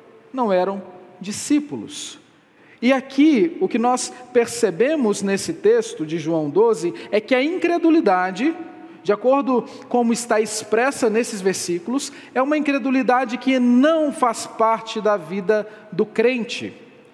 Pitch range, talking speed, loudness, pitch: 210-280 Hz, 125 wpm, -20 LUFS, 245 Hz